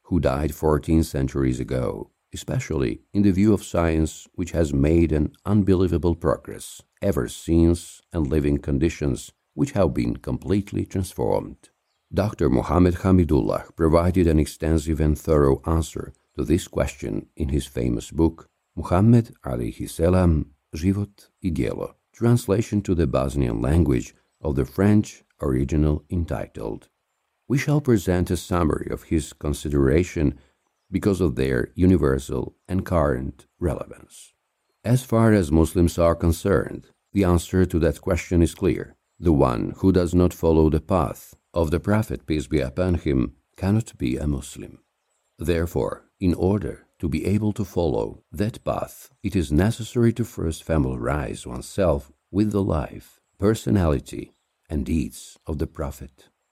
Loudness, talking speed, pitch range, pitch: -23 LUFS, 140 wpm, 75-95 Hz, 85 Hz